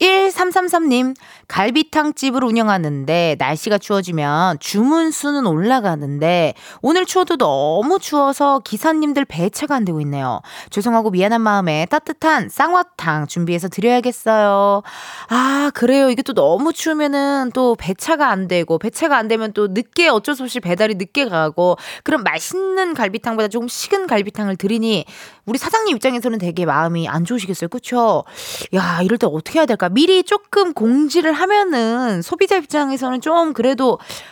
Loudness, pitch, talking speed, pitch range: -17 LUFS, 245 Hz, 340 characters per minute, 195-300 Hz